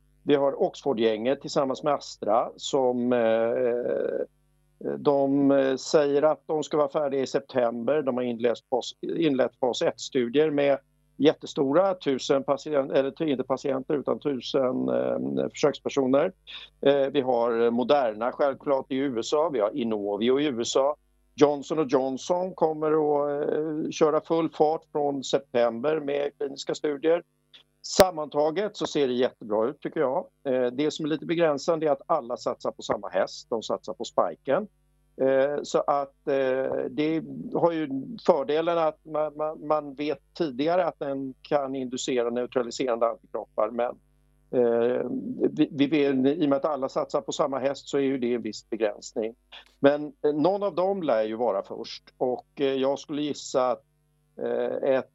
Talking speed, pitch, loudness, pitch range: 135 wpm, 140 Hz, -26 LUFS, 130-155 Hz